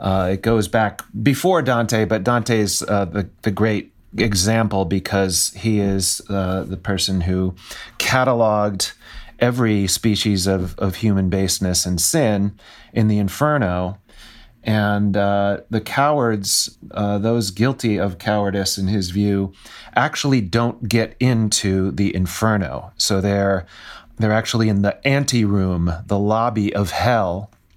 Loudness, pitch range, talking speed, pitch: -19 LUFS, 95-115 Hz, 130 wpm, 105 Hz